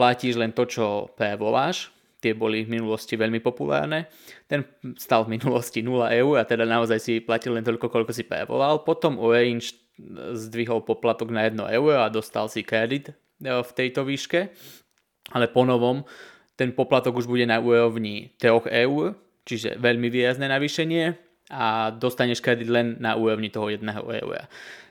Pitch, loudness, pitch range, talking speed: 120 Hz, -24 LUFS, 115-125 Hz, 155 wpm